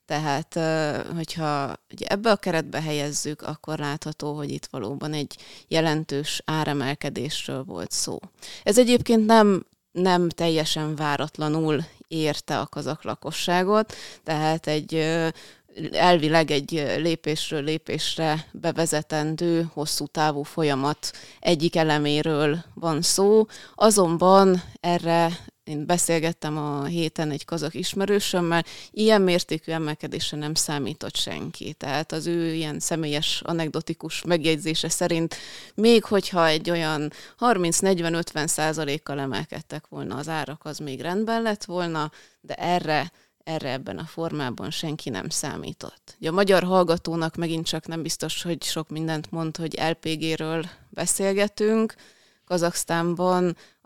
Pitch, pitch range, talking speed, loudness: 160 Hz, 150-175 Hz, 115 wpm, -24 LUFS